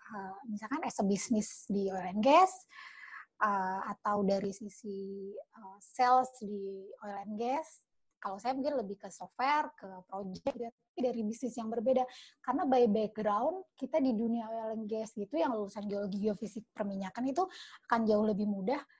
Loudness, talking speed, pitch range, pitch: -34 LUFS, 160 wpm, 200-255 Hz, 220 Hz